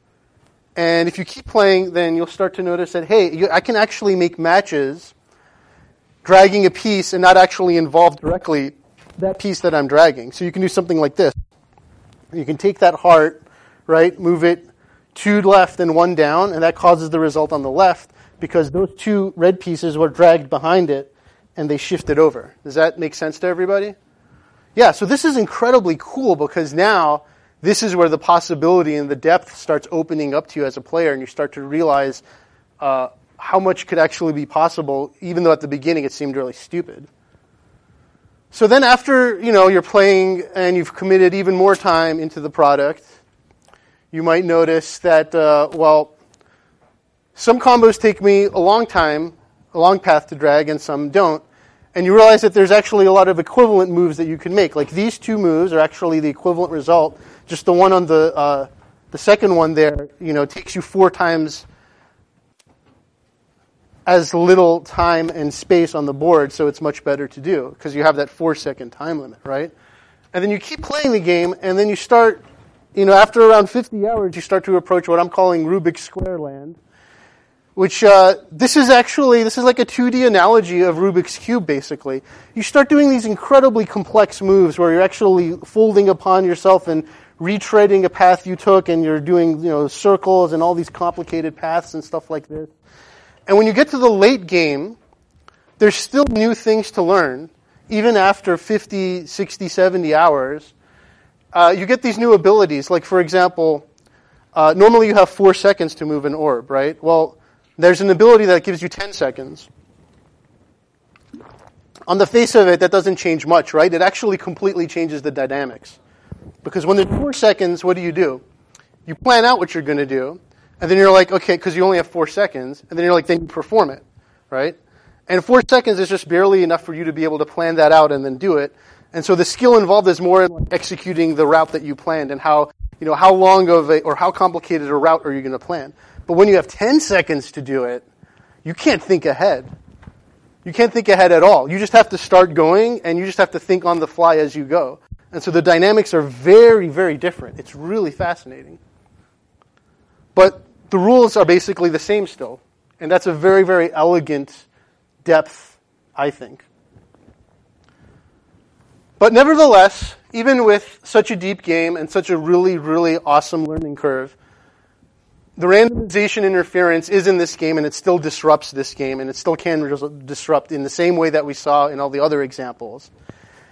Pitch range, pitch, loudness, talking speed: 155-195 Hz, 175 Hz, -15 LUFS, 195 wpm